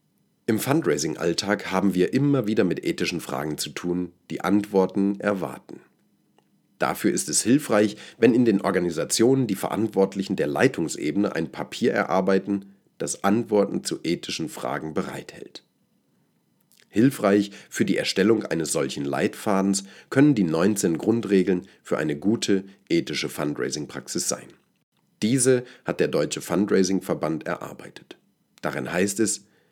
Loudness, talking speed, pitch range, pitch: -24 LUFS, 125 wpm, 90-105 Hz, 95 Hz